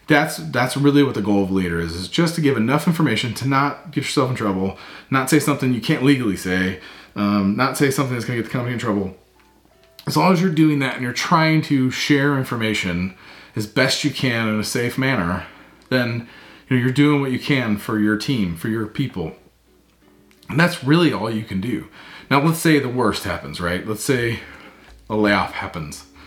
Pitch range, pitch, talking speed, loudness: 105-145 Hz, 125 Hz, 215 wpm, -20 LUFS